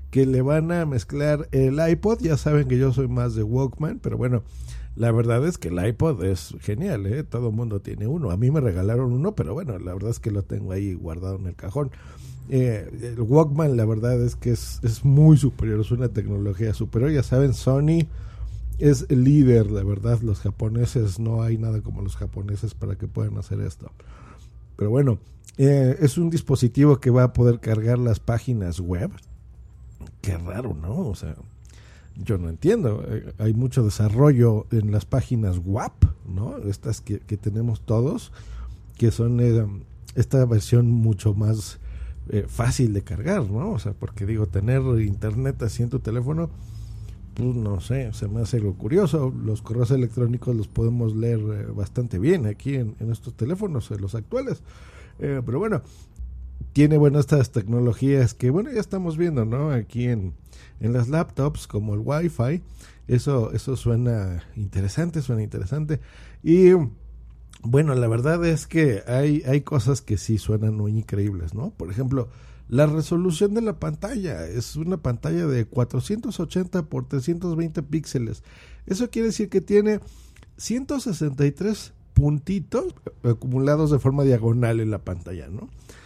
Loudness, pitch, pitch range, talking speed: -23 LUFS, 120 Hz, 105-140 Hz, 165 wpm